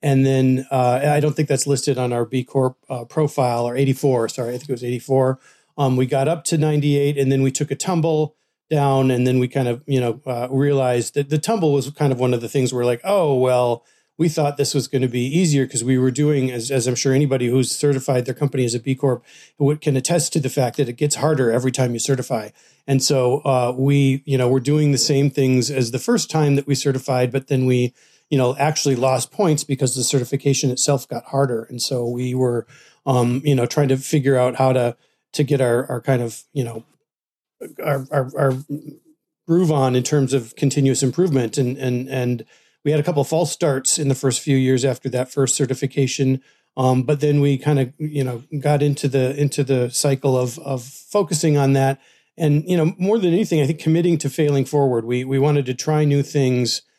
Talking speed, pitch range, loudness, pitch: 230 wpm, 130-145 Hz, -19 LUFS, 135 Hz